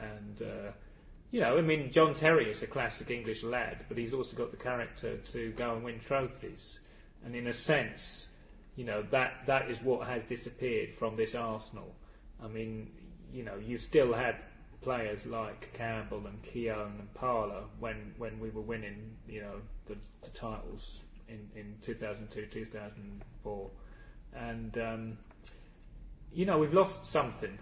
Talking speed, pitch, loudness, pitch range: 160 wpm, 115 Hz, -35 LUFS, 105-120 Hz